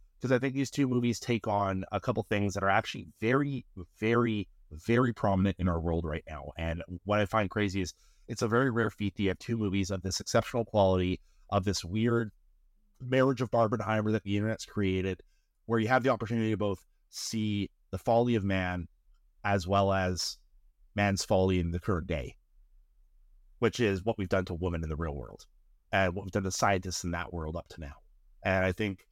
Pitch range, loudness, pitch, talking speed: 90-110 Hz, -31 LUFS, 100 Hz, 205 wpm